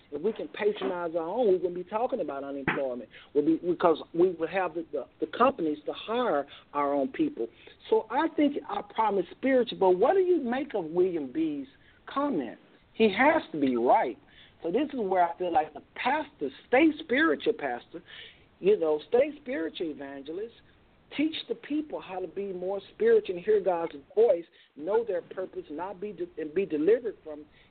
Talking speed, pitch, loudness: 190 wpm, 245 Hz, -28 LUFS